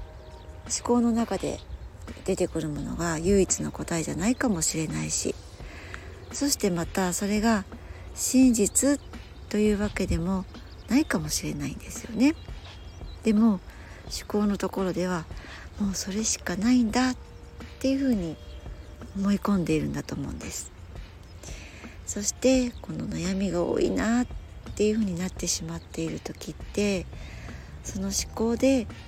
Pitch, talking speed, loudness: 190 Hz, 275 characters per minute, -27 LUFS